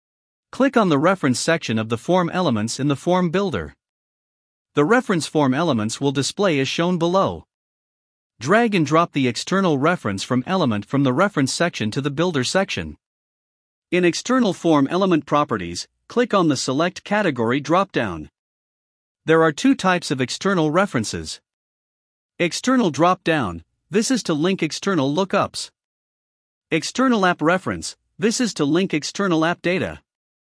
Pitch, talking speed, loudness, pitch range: 165 Hz, 150 wpm, -20 LUFS, 135-185 Hz